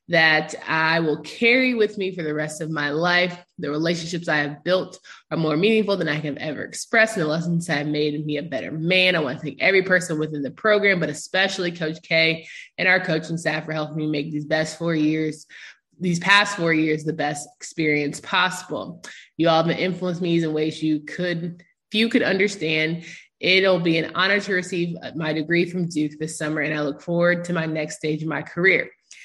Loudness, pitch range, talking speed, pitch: -22 LUFS, 155-180 Hz, 210 wpm, 160 Hz